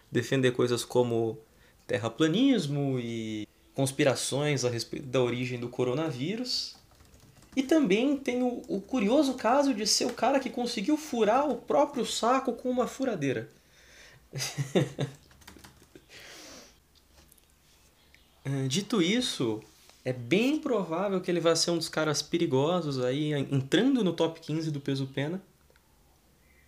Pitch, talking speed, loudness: 150 Hz, 115 wpm, -29 LUFS